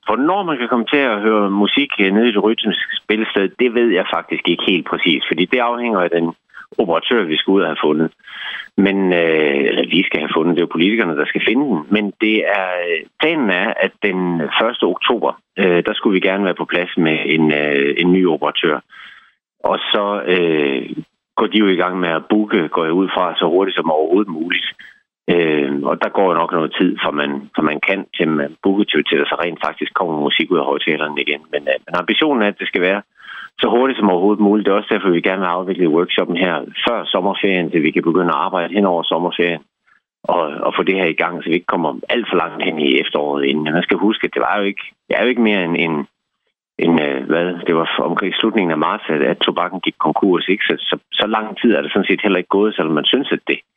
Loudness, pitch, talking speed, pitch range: -16 LUFS, 95 Hz, 240 wpm, 80-105 Hz